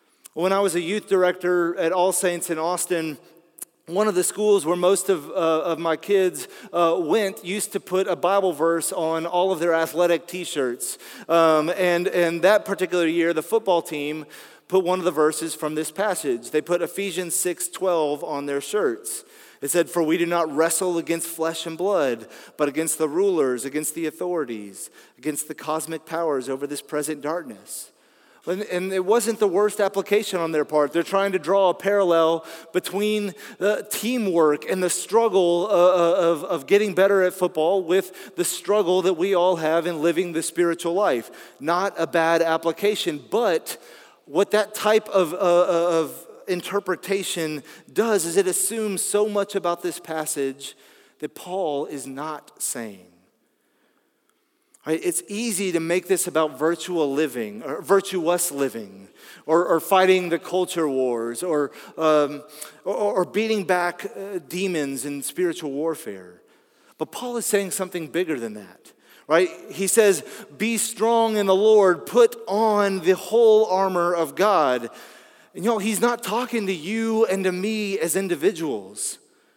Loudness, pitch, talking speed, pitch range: -22 LUFS, 180 Hz, 160 wpm, 160-195 Hz